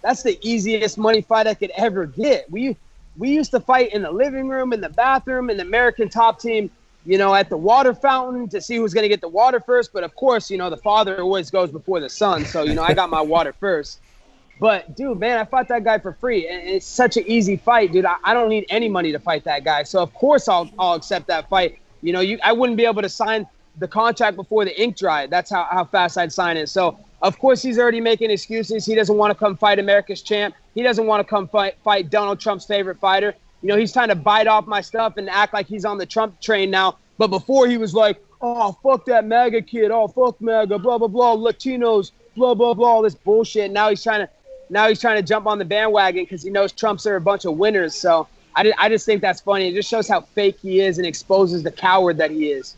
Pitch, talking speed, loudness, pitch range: 210 Hz, 255 wpm, -19 LUFS, 190-230 Hz